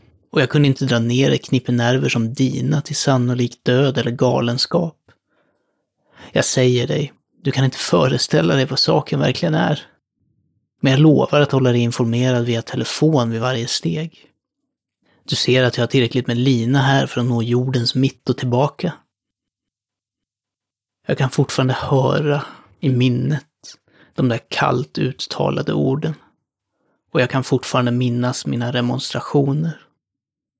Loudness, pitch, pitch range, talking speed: -18 LUFS, 130 Hz, 120-140 Hz, 145 wpm